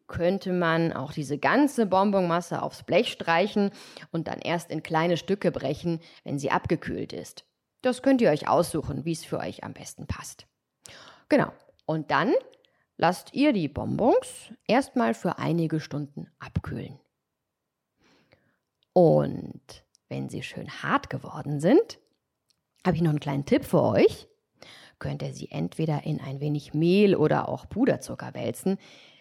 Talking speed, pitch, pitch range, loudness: 145 wpm, 170 Hz, 150-200 Hz, -26 LUFS